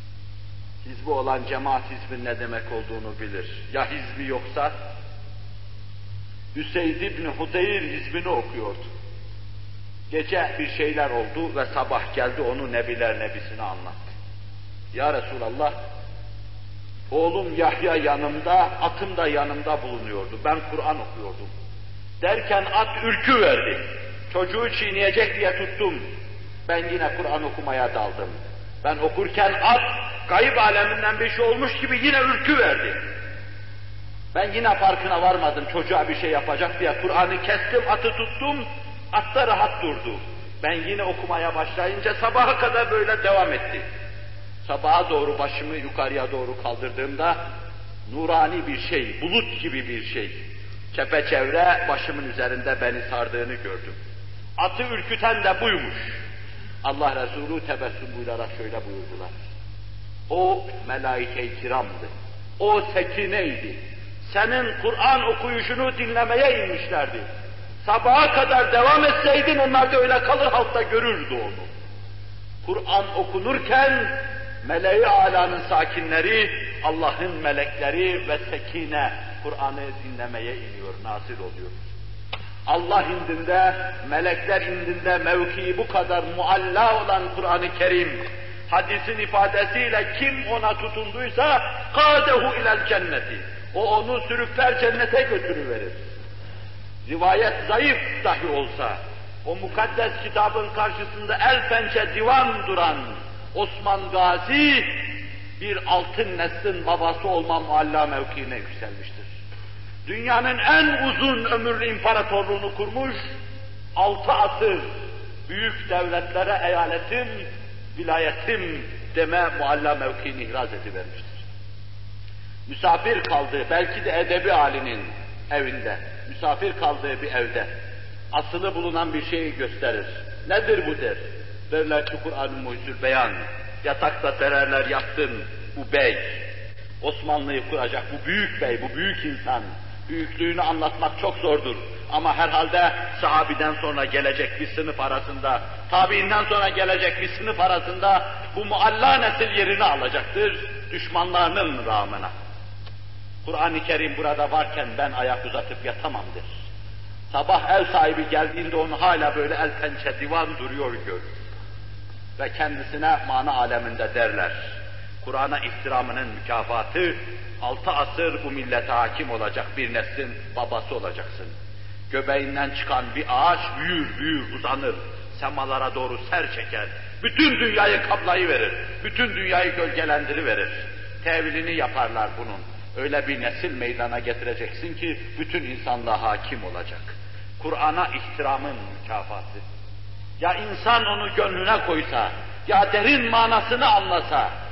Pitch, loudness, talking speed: 125 Hz, -23 LUFS, 110 wpm